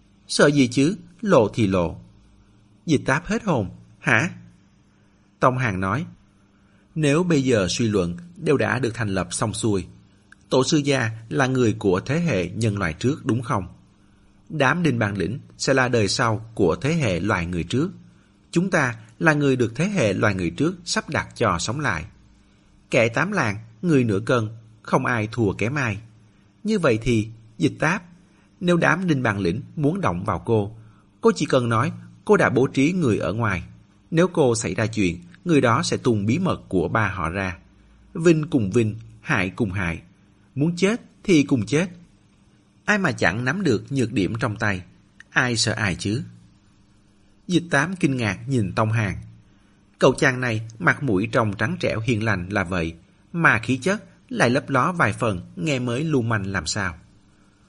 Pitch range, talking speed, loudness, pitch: 100-140 Hz, 185 wpm, -22 LUFS, 115 Hz